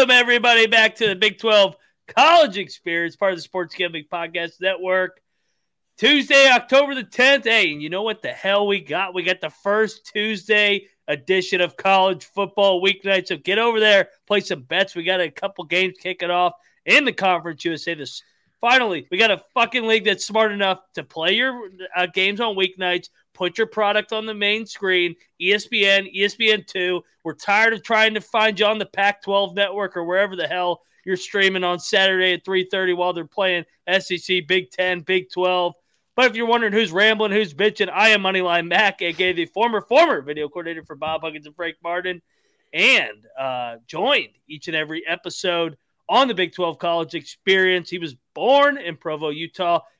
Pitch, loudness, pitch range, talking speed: 190 Hz, -19 LUFS, 175-215 Hz, 190 wpm